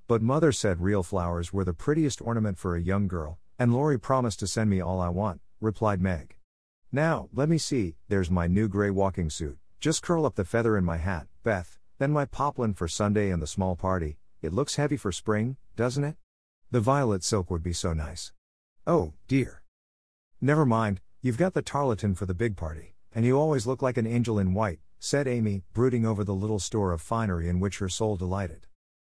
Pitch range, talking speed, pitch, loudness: 90-120 Hz, 210 wpm, 100 Hz, -28 LUFS